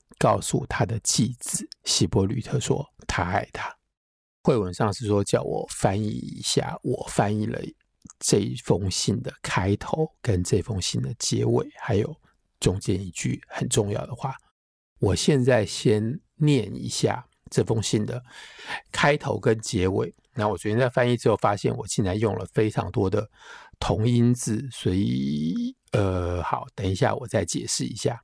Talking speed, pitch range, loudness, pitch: 225 characters per minute, 100-125 Hz, -25 LUFS, 110 Hz